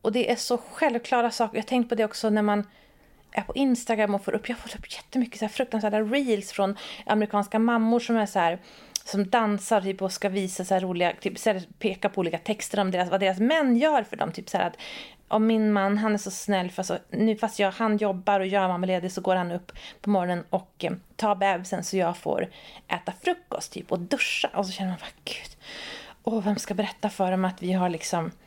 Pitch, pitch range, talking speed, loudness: 205 Hz, 190-225 Hz, 235 wpm, -26 LUFS